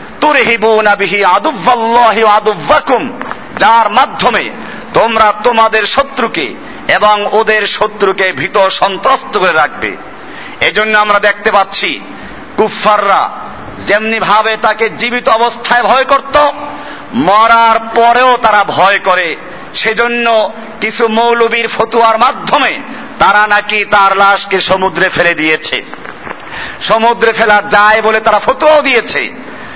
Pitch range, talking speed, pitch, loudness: 205-235 Hz, 85 wpm, 220 Hz, -9 LUFS